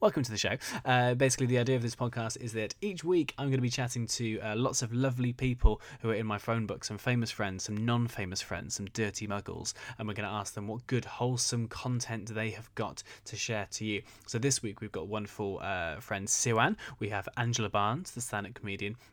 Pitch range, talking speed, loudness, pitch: 105-125 Hz, 230 wpm, -33 LUFS, 115 Hz